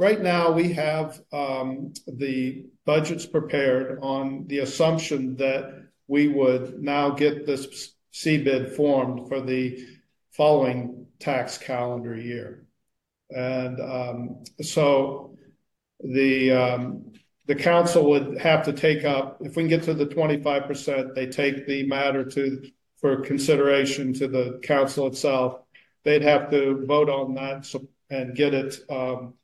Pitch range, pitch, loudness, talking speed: 130-145 Hz, 135 Hz, -24 LUFS, 140 wpm